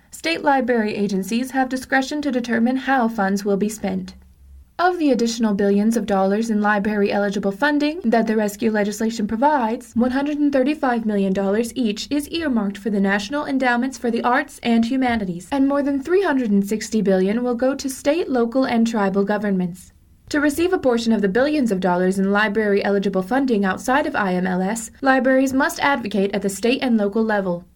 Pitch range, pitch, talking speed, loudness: 205-265 Hz, 230 Hz, 170 wpm, -20 LUFS